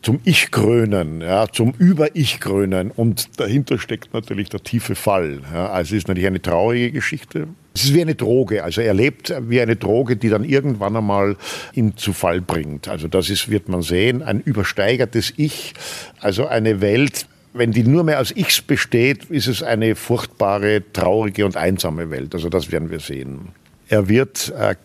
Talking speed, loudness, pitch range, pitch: 185 wpm, -18 LUFS, 95-125 Hz, 110 Hz